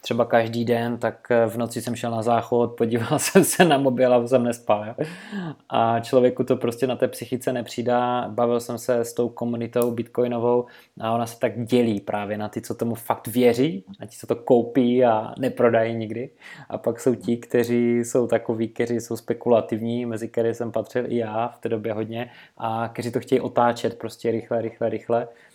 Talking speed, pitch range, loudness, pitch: 195 wpm, 115-125 Hz, -23 LUFS, 120 Hz